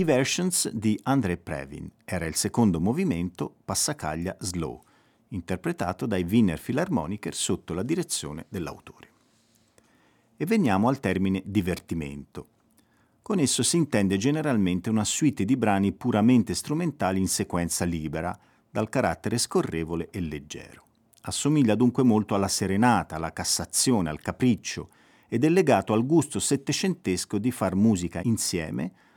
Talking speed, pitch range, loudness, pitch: 125 wpm, 90-125 Hz, -26 LUFS, 100 Hz